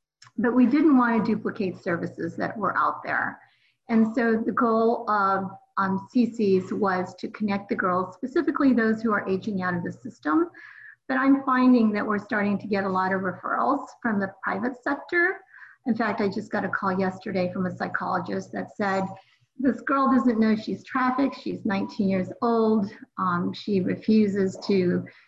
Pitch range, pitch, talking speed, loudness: 195-250 Hz, 220 Hz, 180 wpm, -25 LUFS